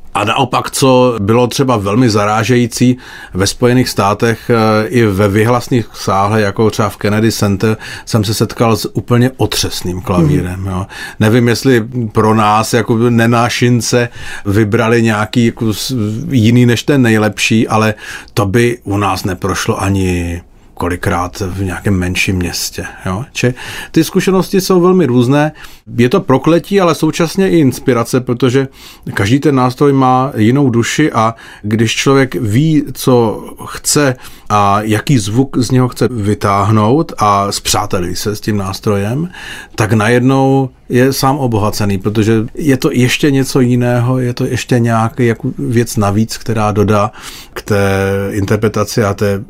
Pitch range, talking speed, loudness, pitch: 105-130 Hz, 140 wpm, -12 LUFS, 115 Hz